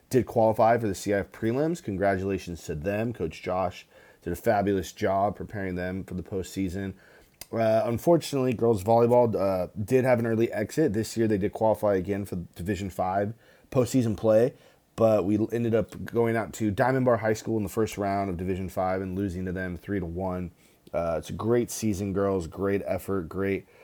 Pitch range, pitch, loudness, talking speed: 95-115 Hz, 100 Hz, -27 LUFS, 190 wpm